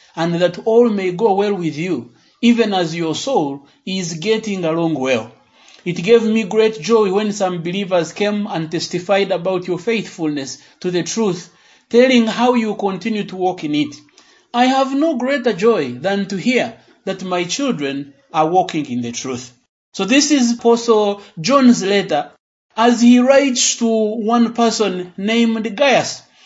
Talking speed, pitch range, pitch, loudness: 160 wpm, 175-230 Hz, 200 Hz, -17 LUFS